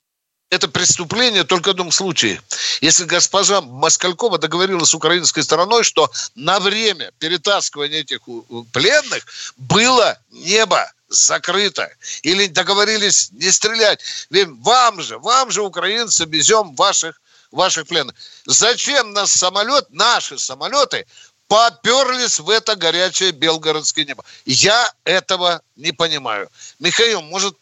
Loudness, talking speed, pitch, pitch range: -15 LUFS, 120 wpm, 185 Hz, 165-215 Hz